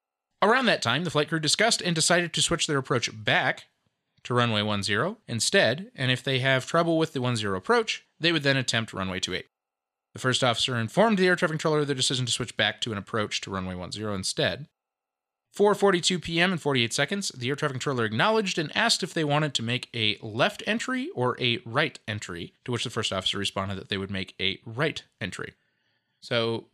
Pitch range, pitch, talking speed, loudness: 115-175 Hz, 135 Hz, 205 wpm, -25 LUFS